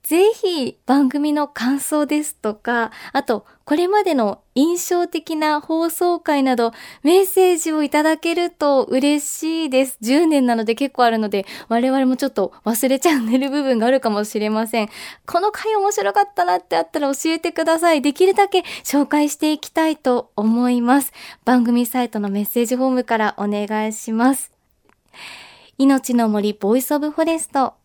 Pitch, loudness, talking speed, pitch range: 275 Hz, -18 LUFS, 340 characters per minute, 235-320 Hz